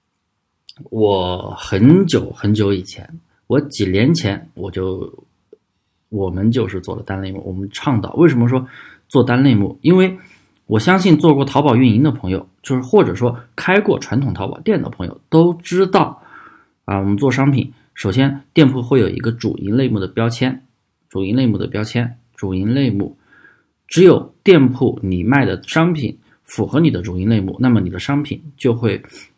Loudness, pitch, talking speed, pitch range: -16 LUFS, 120 Hz, 255 characters per minute, 100-135 Hz